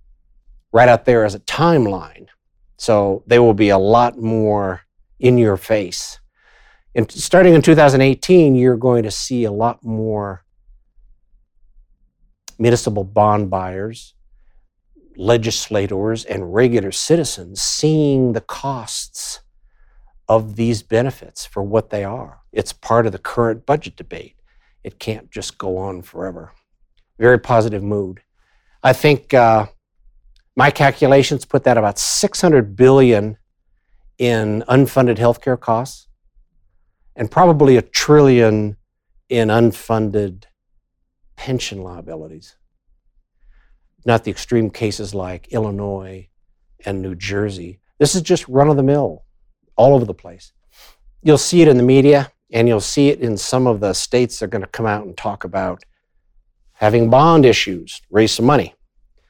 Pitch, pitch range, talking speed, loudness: 115 Hz, 100-125 Hz, 130 wpm, -15 LUFS